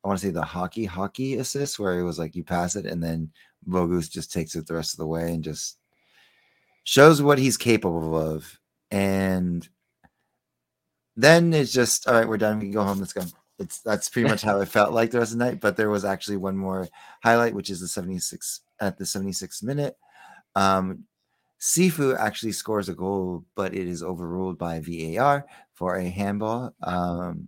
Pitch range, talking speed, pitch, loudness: 90-115 Hz, 200 wpm, 95 Hz, -24 LUFS